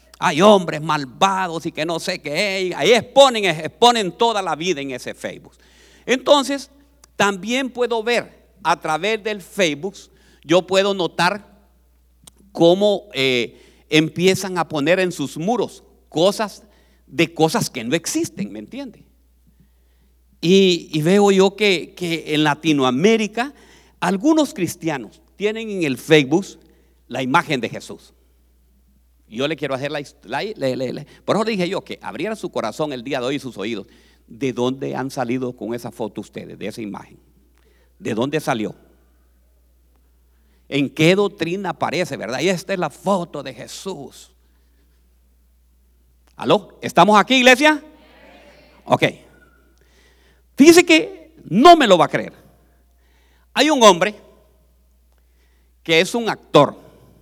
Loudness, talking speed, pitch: -18 LUFS, 135 wpm, 165 Hz